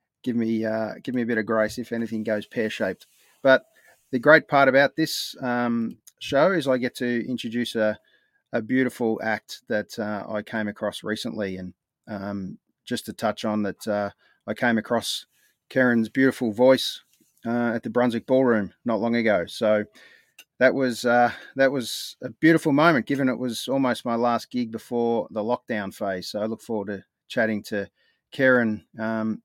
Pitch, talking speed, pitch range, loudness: 115 Hz, 175 wpm, 110-125 Hz, -24 LUFS